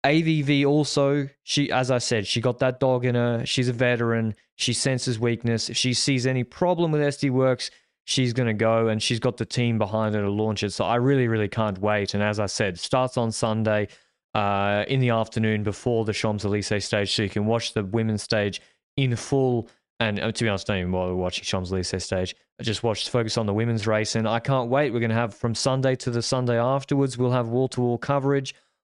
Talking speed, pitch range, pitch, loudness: 225 wpm, 110-130 Hz, 115 Hz, -24 LUFS